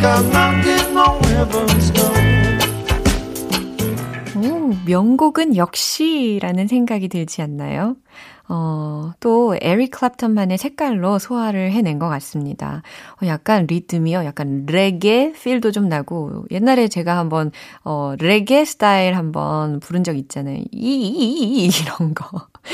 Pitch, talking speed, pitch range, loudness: 180 Hz, 215 characters per minute, 145-225 Hz, -18 LUFS